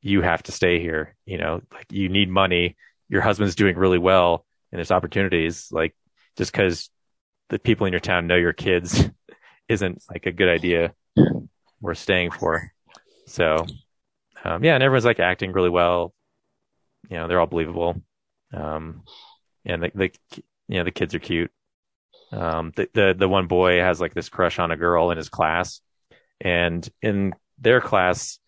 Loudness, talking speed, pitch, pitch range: -22 LUFS, 175 wpm, 90 Hz, 85-95 Hz